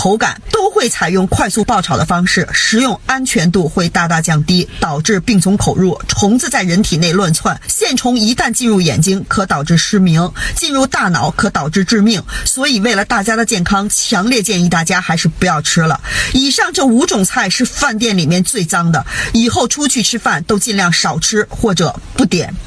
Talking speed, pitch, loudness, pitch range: 290 characters per minute, 200 Hz, -12 LUFS, 175-235 Hz